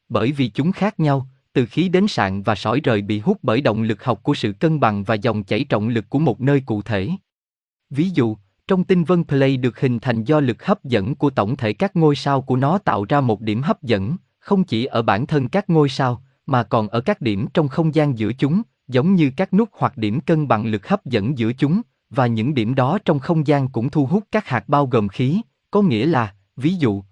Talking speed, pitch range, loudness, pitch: 245 wpm, 115-160 Hz, -19 LUFS, 135 Hz